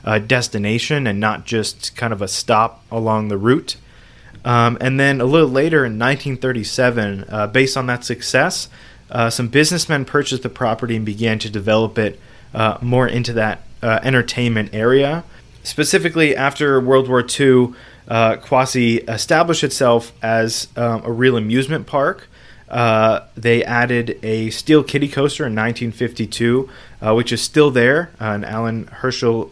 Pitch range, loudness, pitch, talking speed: 110-130 Hz, -17 LUFS, 120 Hz, 155 wpm